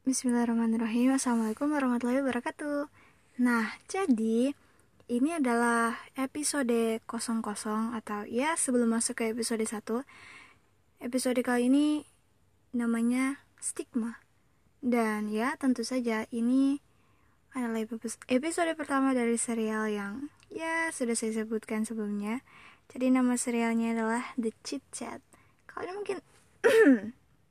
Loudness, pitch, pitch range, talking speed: -30 LUFS, 240 Hz, 230-270 Hz, 105 wpm